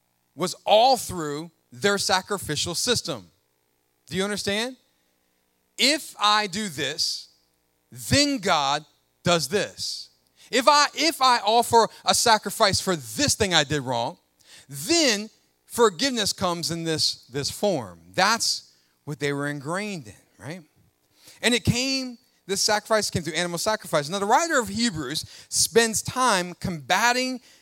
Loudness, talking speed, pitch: -23 LUFS, 135 wpm, 185 Hz